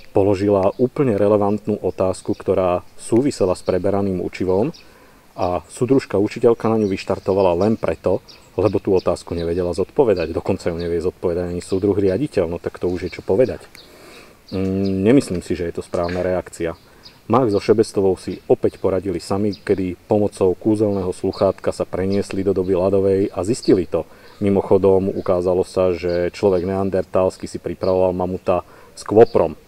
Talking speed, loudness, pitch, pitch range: 150 wpm, -19 LUFS, 95 Hz, 90-100 Hz